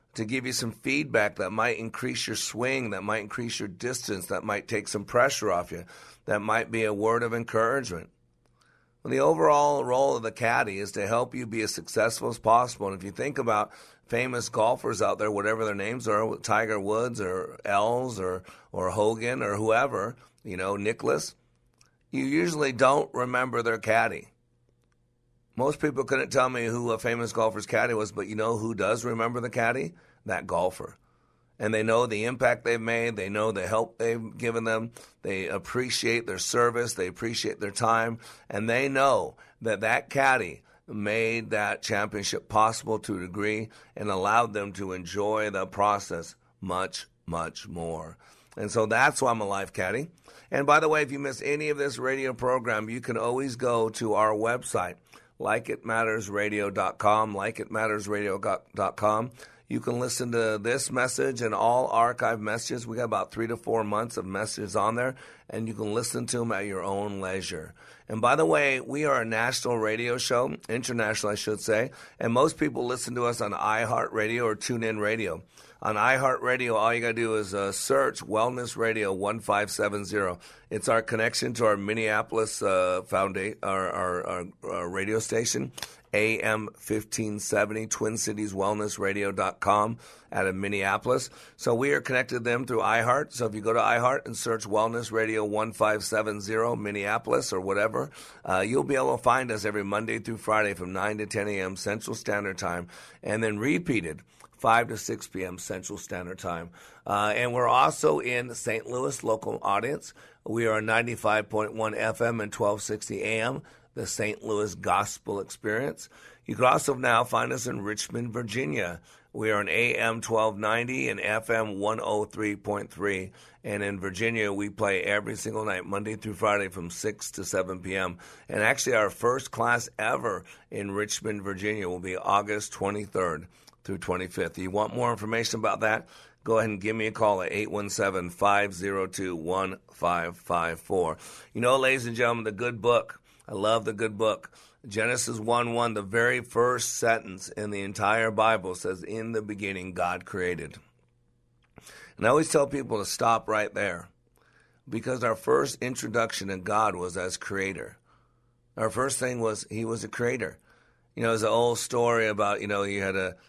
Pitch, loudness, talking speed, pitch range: 110 Hz, -28 LUFS, 180 wpm, 100-115 Hz